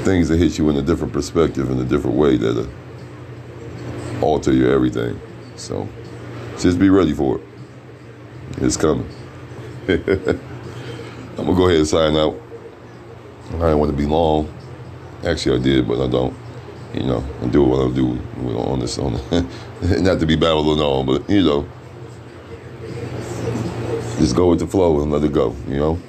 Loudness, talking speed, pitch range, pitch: -18 LUFS, 170 wpm, 65-90 Hz, 75 Hz